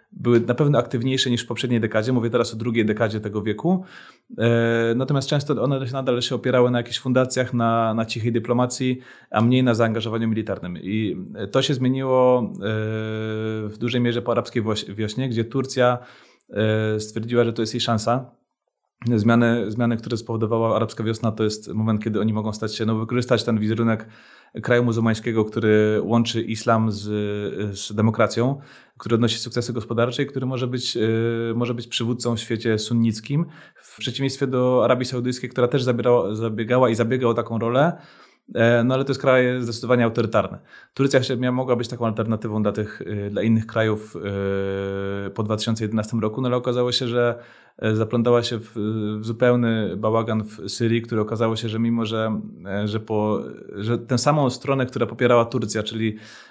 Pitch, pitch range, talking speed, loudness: 115 Hz, 110-125 Hz, 160 wpm, -22 LUFS